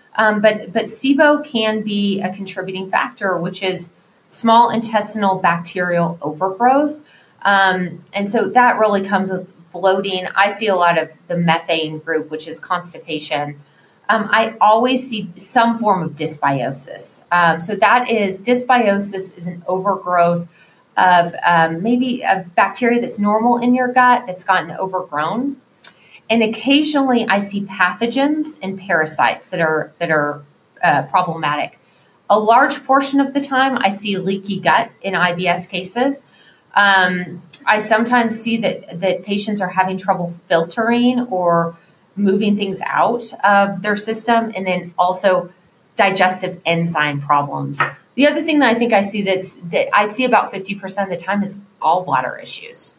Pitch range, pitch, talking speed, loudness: 175-225 Hz, 195 Hz, 150 wpm, -16 LUFS